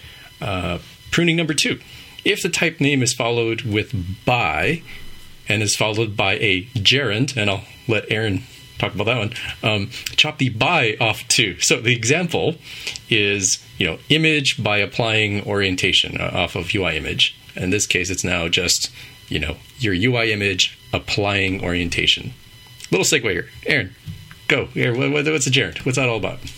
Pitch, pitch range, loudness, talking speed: 115 Hz, 100-130 Hz, -19 LUFS, 165 wpm